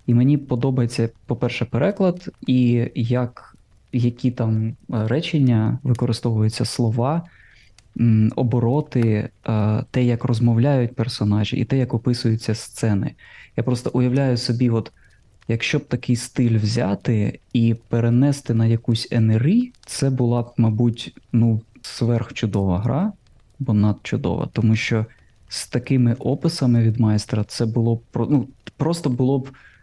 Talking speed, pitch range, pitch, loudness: 120 wpm, 110-125 Hz, 120 Hz, -21 LUFS